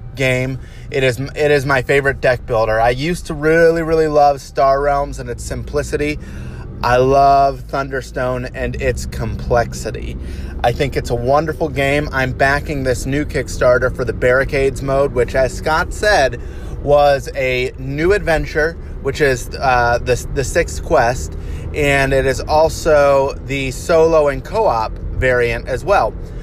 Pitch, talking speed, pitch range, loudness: 135 Hz, 150 wpm, 125-145 Hz, -16 LUFS